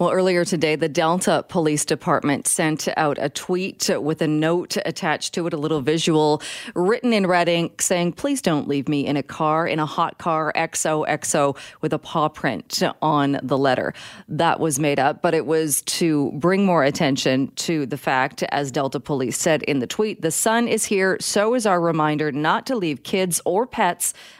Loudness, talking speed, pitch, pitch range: -21 LUFS, 195 wpm, 160 Hz, 150-180 Hz